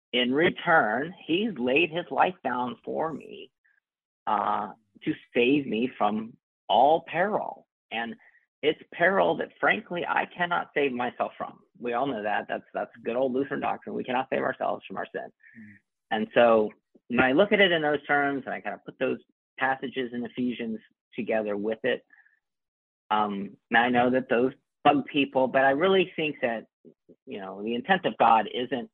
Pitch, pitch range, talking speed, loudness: 125 Hz, 110-140 Hz, 175 wpm, -26 LUFS